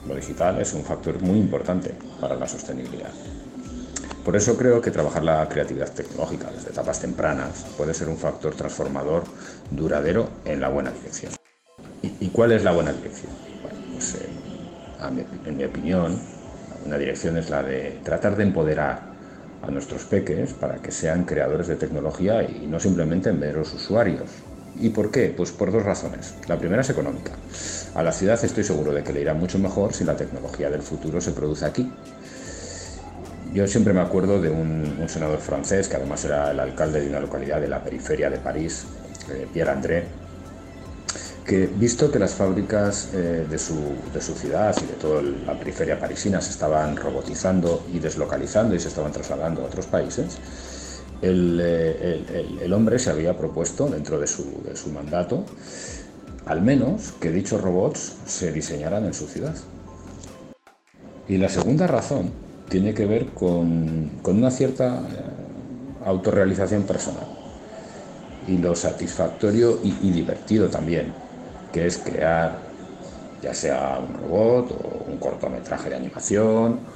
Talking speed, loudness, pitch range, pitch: 160 wpm, -24 LUFS, 80-95 Hz, 90 Hz